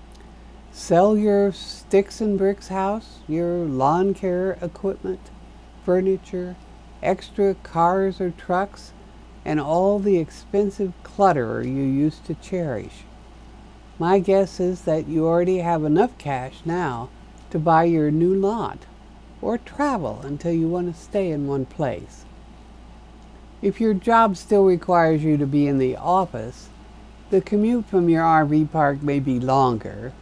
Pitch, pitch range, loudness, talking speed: 175 Hz, 150-195 Hz, -21 LUFS, 135 wpm